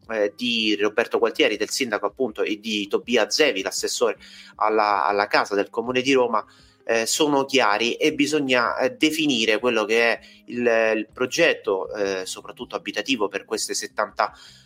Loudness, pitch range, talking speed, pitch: -22 LUFS, 105-140 Hz, 150 wpm, 115 Hz